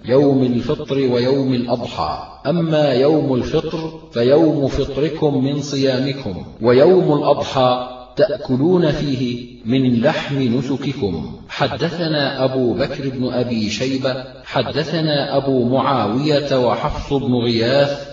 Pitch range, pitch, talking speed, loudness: 125-145 Hz, 135 Hz, 100 wpm, -18 LUFS